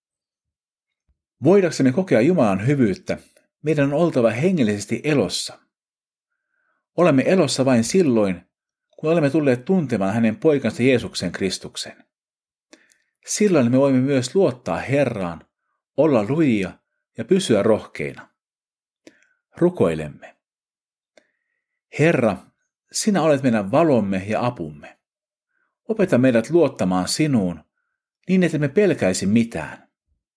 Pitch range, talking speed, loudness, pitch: 110-185 Hz, 95 wpm, -20 LUFS, 140 Hz